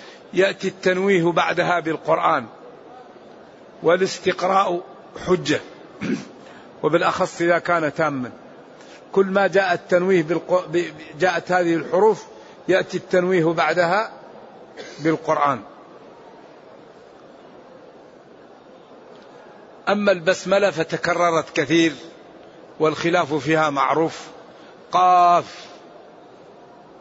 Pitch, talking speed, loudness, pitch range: 175 Hz, 65 wpm, -20 LUFS, 160-185 Hz